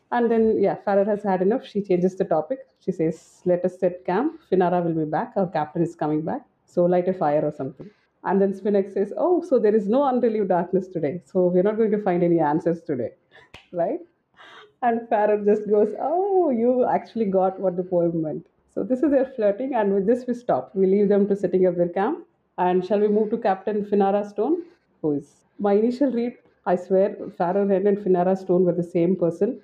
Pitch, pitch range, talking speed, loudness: 195 Hz, 180-220 Hz, 215 wpm, -22 LUFS